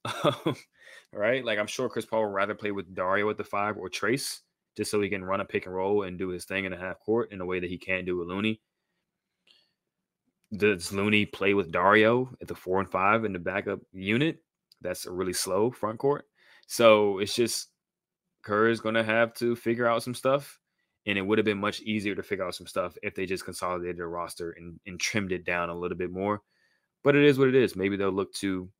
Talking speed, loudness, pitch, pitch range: 235 wpm, -28 LUFS, 105 Hz, 95-120 Hz